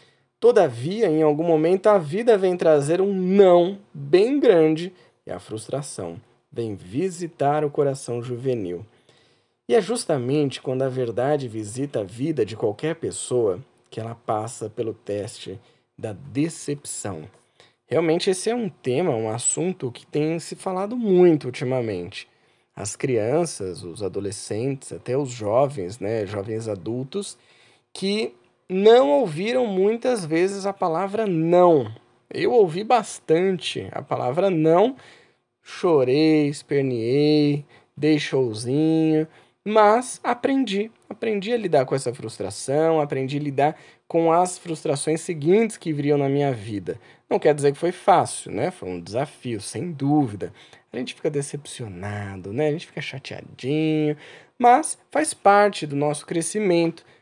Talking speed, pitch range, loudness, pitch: 130 wpm, 125-185 Hz, -22 LUFS, 150 Hz